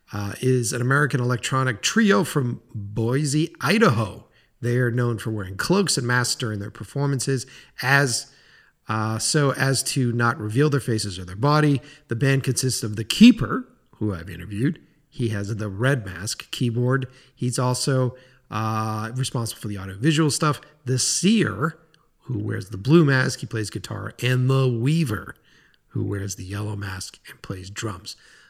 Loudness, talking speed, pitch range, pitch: -23 LUFS, 160 wpm, 110-140 Hz, 125 Hz